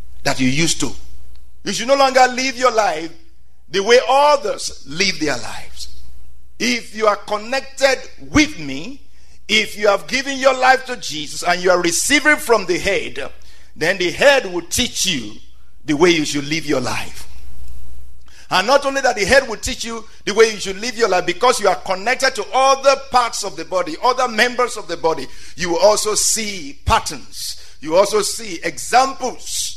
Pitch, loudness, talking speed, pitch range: 205 Hz, -17 LUFS, 185 wpm, 155-255 Hz